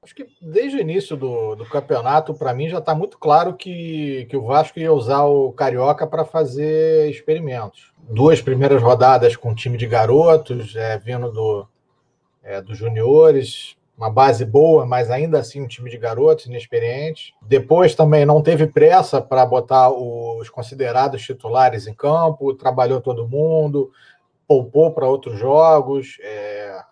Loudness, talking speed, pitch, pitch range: -16 LUFS, 155 wpm, 135 Hz, 120-155 Hz